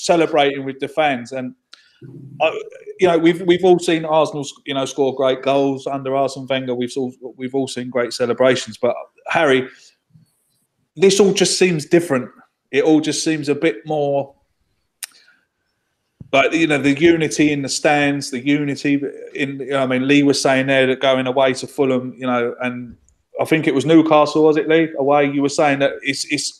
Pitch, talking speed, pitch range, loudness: 140 Hz, 190 wpm, 130-155 Hz, -17 LUFS